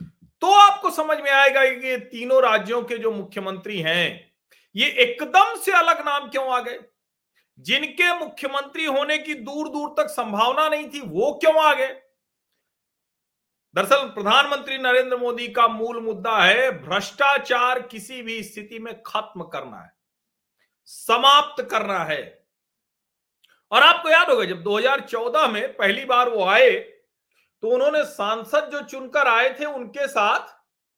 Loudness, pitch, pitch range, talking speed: -20 LUFS, 265 Hz, 230-300 Hz, 140 wpm